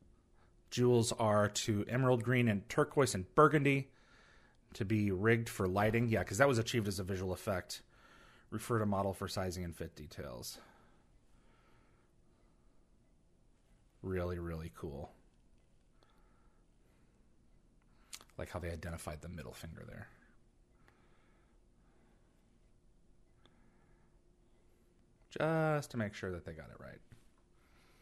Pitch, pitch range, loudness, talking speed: 100 Hz, 85-120 Hz, -35 LUFS, 110 wpm